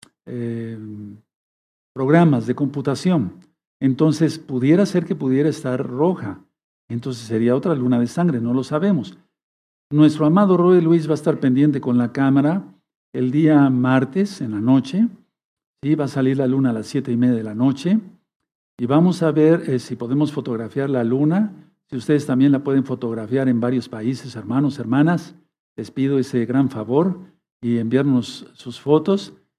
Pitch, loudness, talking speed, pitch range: 135 Hz, -19 LUFS, 165 wpm, 125-155 Hz